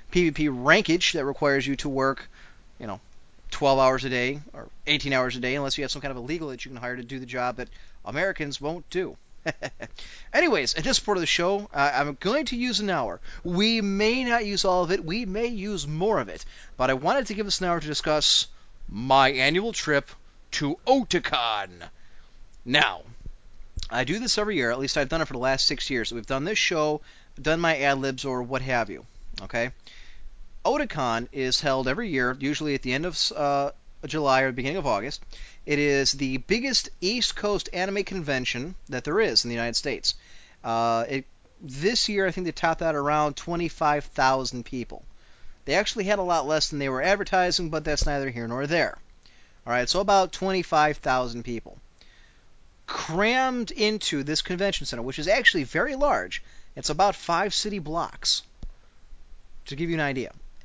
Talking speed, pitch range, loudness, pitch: 190 wpm, 130-185 Hz, -25 LUFS, 145 Hz